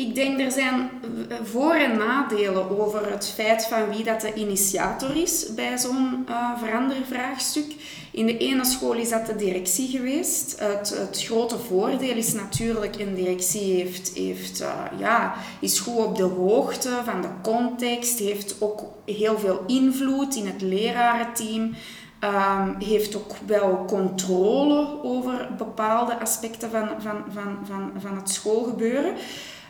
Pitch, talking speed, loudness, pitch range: 225 Hz, 145 wpm, -24 LUFS, 200-250 Hz